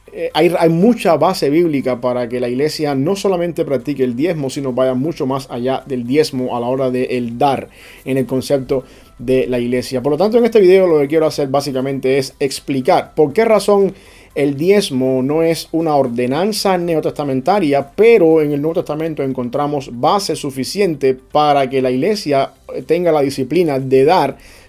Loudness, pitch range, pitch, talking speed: -15 LUFS, 130-165 Hz, 140 Hz, 175 wpm